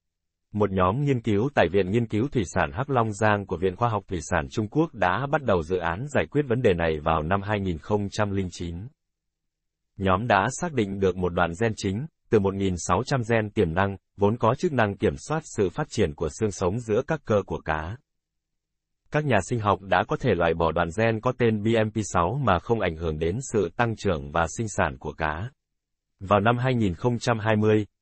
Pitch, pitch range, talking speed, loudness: 105 Hz, 90-120 Hz, 205 wpm, -25 LUFS